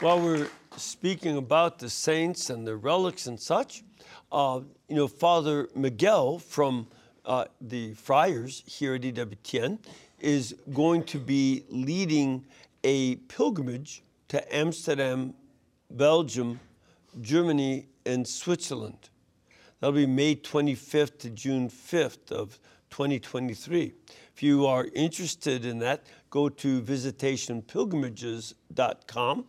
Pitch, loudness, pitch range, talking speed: 135 Hz, -28 LUFS, 125-155 Hz, 110 wpm